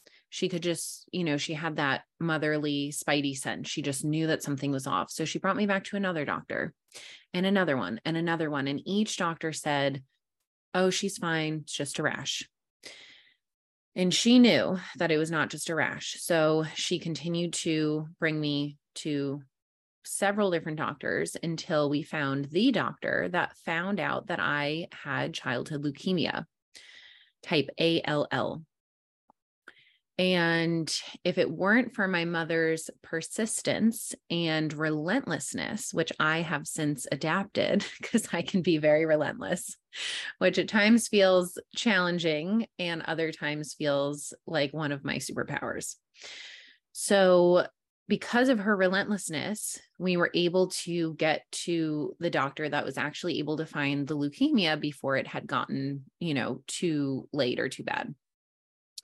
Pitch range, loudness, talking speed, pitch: 150-185 Hz, -29 LUFS, 145 wpm, 165 Hz